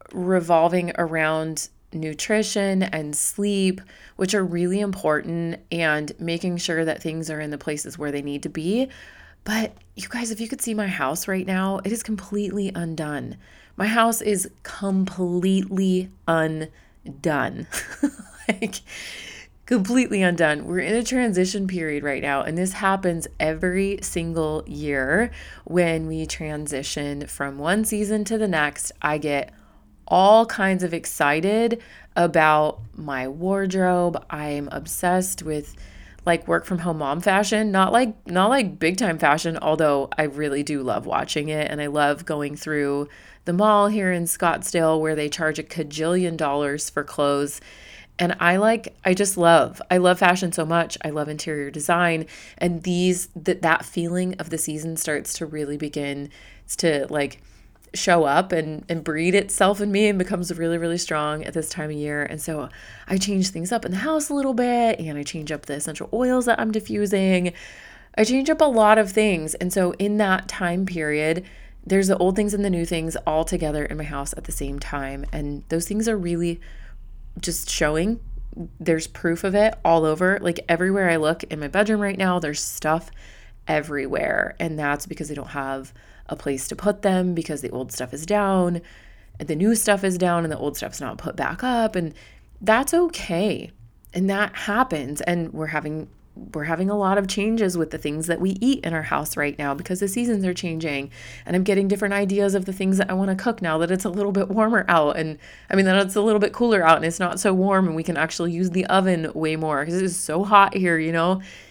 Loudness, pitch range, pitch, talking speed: -22 LUFS, 155-195 Hz, 175 Hz, 190 wpm